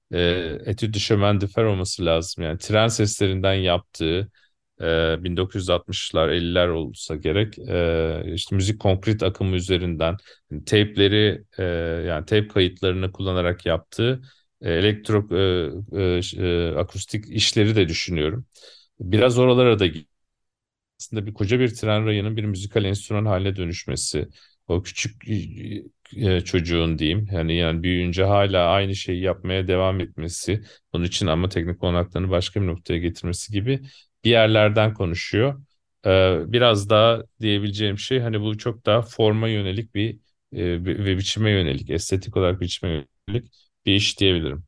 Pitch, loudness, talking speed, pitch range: 95 Hz, -22 LUFS, 125 wpm, 85-105 Hz